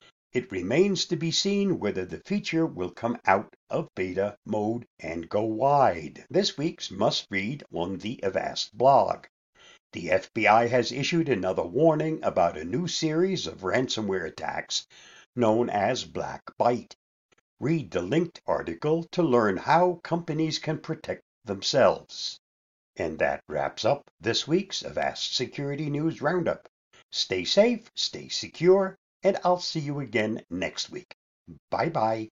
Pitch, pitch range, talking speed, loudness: 155 Hz, 110-170 Hz, 140 wpm, -27 LUFS